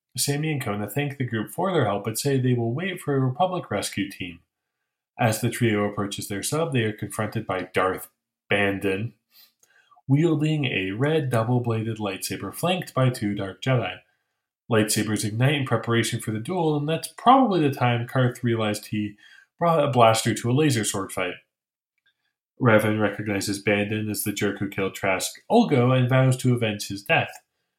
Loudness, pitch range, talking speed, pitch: -24 LUFS, 105-140 Hz, 175 wpm, 115 Hz